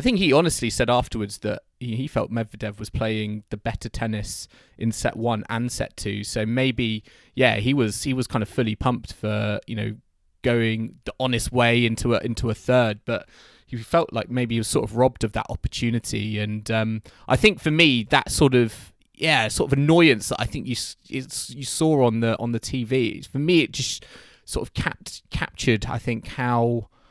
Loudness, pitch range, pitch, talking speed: -23 LUFS, 110-125 Hz, 115 Hz, 205 wpm